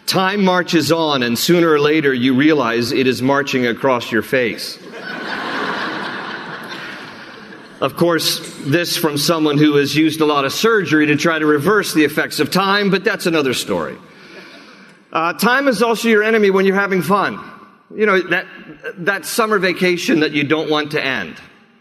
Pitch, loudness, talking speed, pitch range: 165 Hz, -16 LUFS, 170 wpm, 150-190 Hz